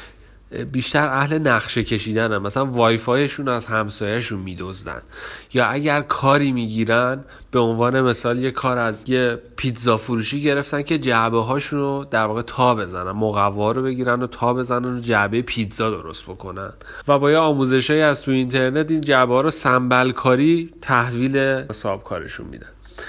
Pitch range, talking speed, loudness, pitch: 115-135 Hz, 155 wpm, -20 LUFS, 125 Hz